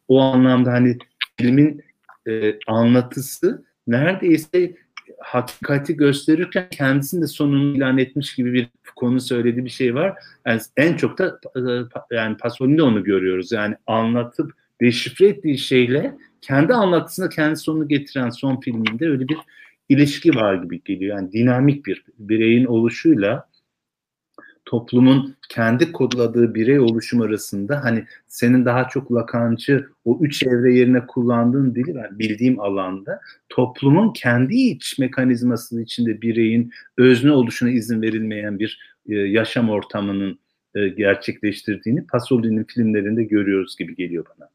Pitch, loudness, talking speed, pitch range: 125 Hz, -19 LUFS, 130 wpm, 115-140 Hz